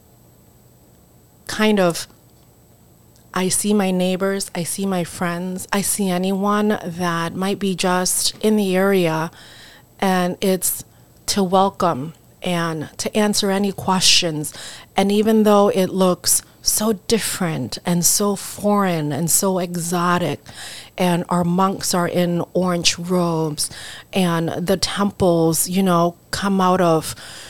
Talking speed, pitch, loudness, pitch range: 125 wpm, 180 Hz, -19 LUFS, 170-195 Hz